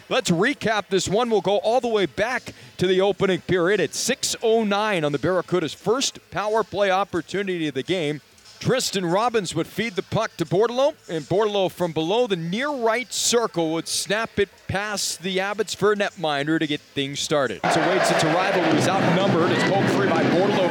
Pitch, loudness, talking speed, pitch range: 190 Hz, -22 LUFS, 195 wpm, 165-215 Hz